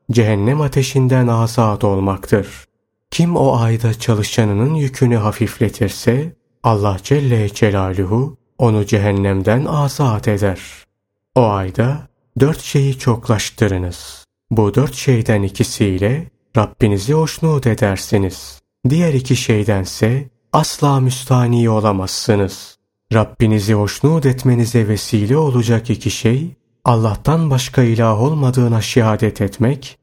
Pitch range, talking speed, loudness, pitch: 105-130 Hz, 95 wpm, -16 LUFS, 115 Hz